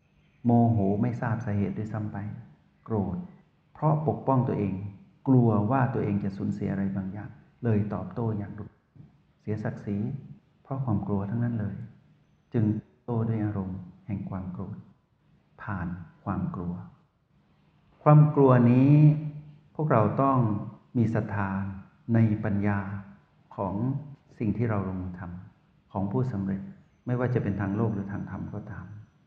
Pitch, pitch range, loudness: 110 Hz, 100-125 Hz, -27 LUFS